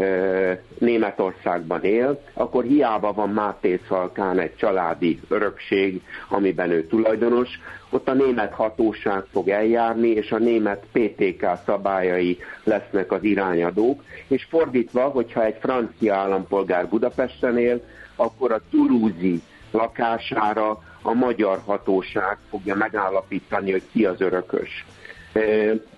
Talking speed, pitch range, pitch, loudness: 110 wpm, 95-115 Hz, 105 Hz, -22 LUFS